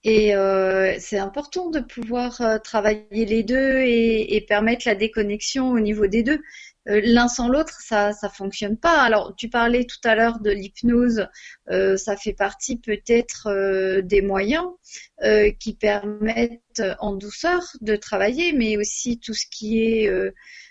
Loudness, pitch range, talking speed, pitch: -21 LUFS, 205-240 Hz, 160 wpm, 220 Hz